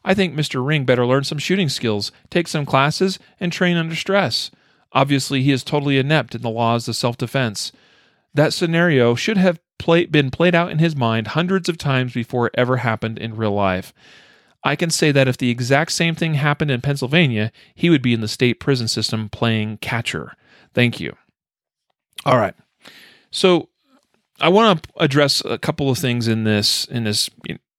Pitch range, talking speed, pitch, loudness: 115-165 Hz, 190 wpm, 135 Hz, -19 LUFS